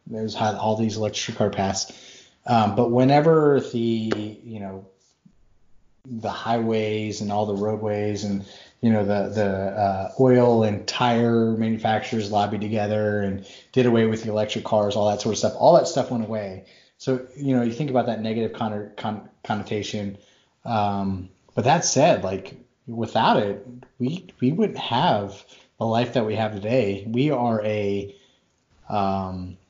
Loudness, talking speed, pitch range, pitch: -23 LUFS, 155 wpm, 100-120 Hz, 110 Hz